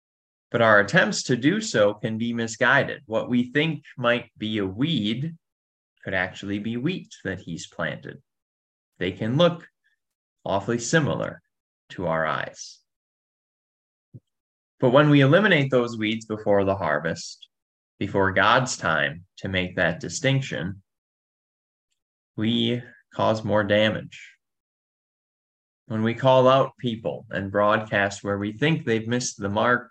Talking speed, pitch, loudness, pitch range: 130 wpm, 115 Hz, -23 LUFS, 100-130 Hz